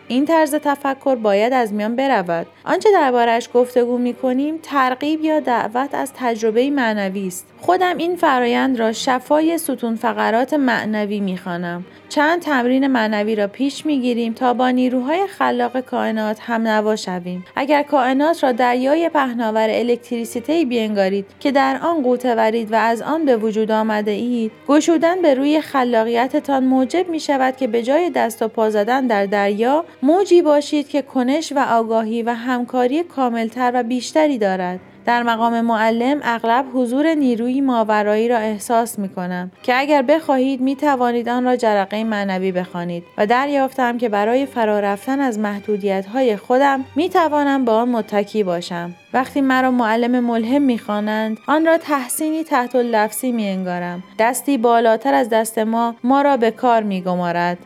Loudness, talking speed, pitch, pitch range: -18 LUFS, 150 wpm, 245 Hz, 220-275 Hz